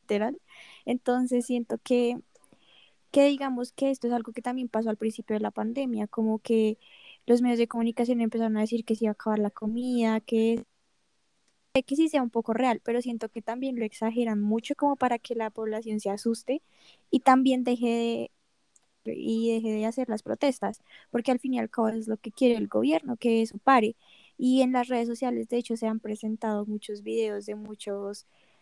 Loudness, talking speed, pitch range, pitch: -28 LUFS, 200 wpm, 220-250 Hz, 235 Hz